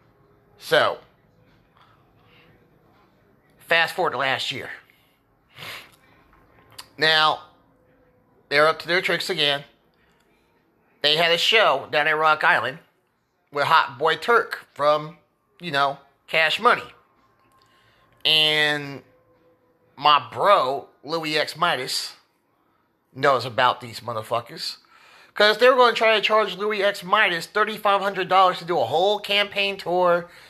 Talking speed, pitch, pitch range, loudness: 115 wpm, 160 Hz, 140-195 Hz, -20 LUFS